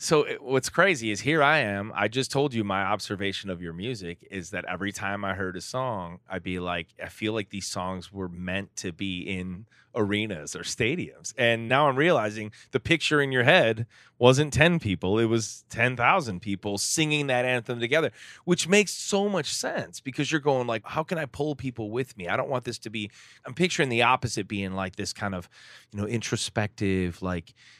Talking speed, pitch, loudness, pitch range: 205 wpm, 110 Hz, -26 LUFS, 95-130 Hz